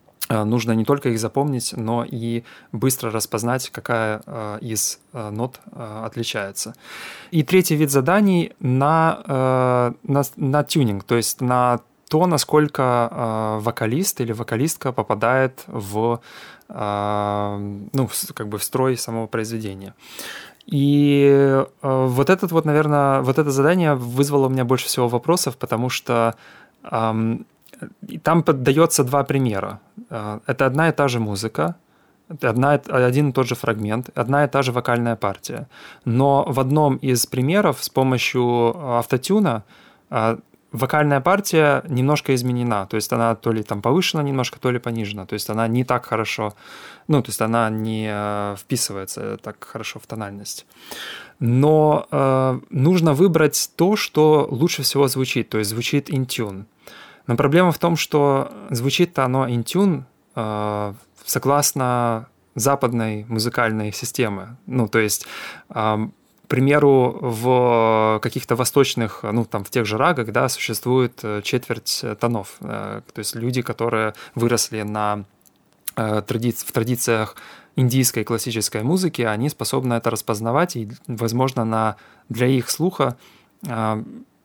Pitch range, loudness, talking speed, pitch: 110-140 Hz, -20 LUFS, 130 wpm, 125 Hz